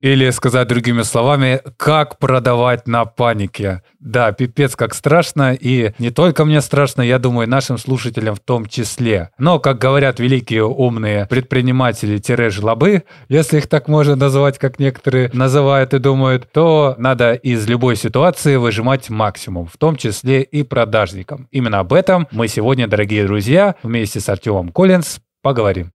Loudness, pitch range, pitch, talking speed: -15 LUFS, 115-140 Hz, 130 Hz, 155 wpm